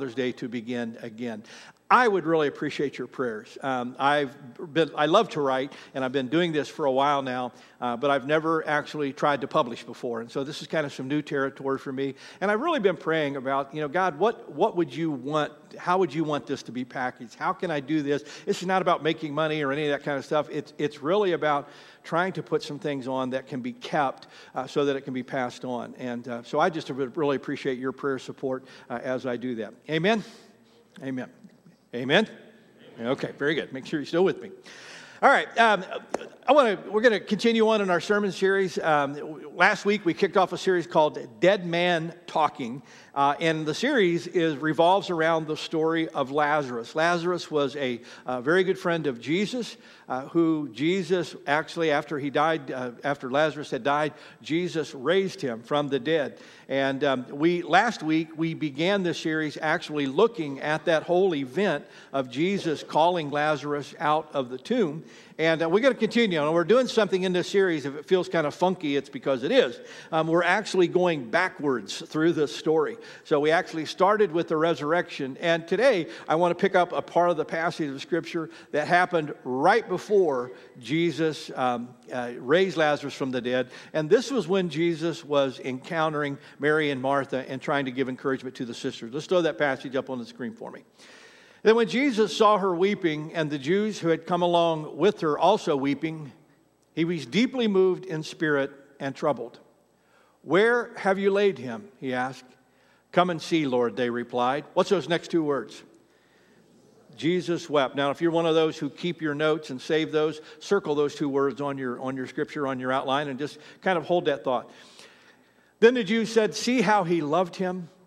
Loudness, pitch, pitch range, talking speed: -26 LUFS, 155 Hz, 140-175 Hz, 205 wpm